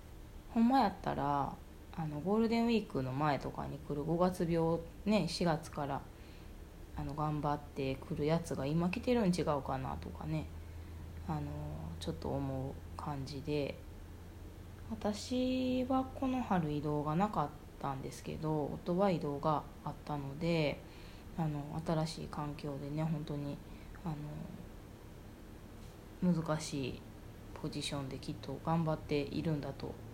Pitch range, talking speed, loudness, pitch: 105-165 Hz, 255 characters per minute, -37 LUFS, 145 Hz